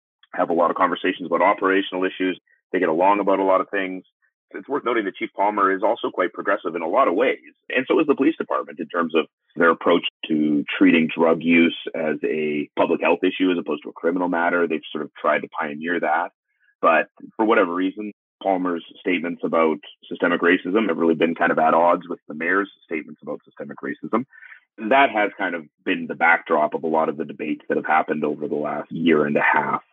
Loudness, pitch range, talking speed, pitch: -21 LUFS, 85-105 Hz, 225 wpm, 95 Hz